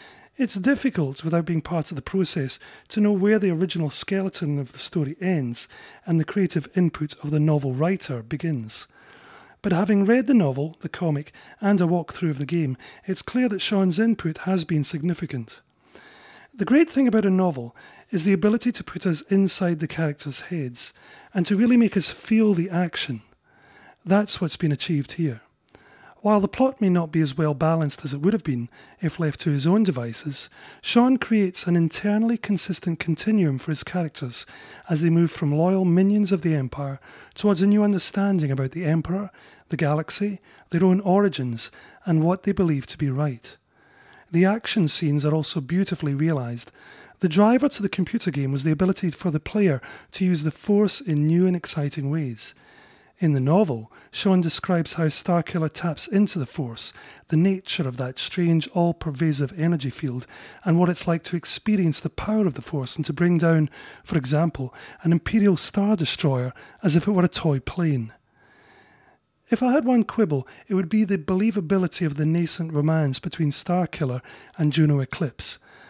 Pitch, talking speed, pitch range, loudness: 170 Hz, 180 wpm, 150-195 Hz, -23 LUFS